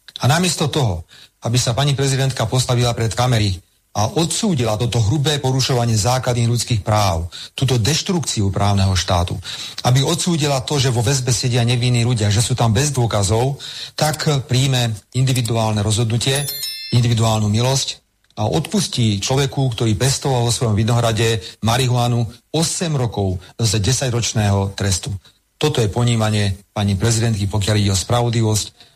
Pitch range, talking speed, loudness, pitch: 110-130 Hz, 135 wpm, -18 LUFS, 120 Hz